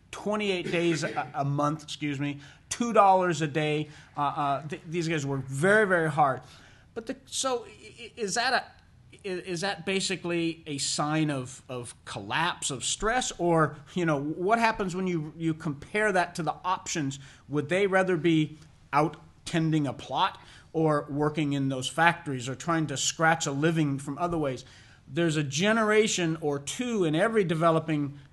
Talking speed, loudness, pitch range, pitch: 170 wpm, -27 LUFS, 145-180 Hz, 160 Hz